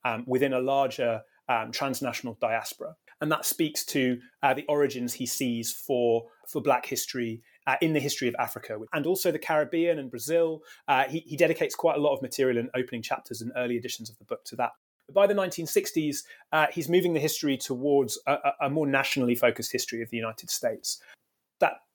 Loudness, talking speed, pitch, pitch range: -28 LUFS, 195 wpm, 140 Hz, 125-160 Hz